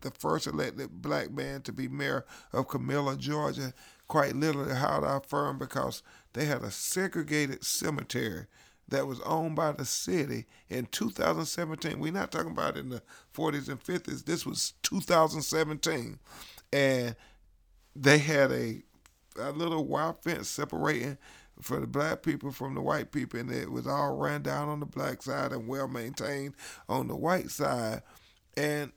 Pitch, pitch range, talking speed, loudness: 145 Hz, 135-155 Hz, 160 wpm, -32 LUFS